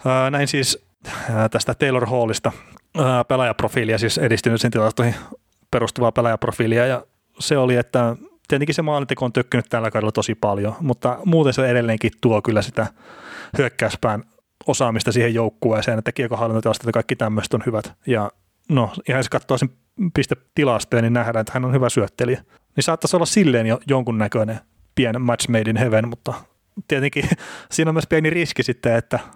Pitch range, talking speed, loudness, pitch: 115-135 Hz, 155 wpm, -20 LUFS, 125 Hz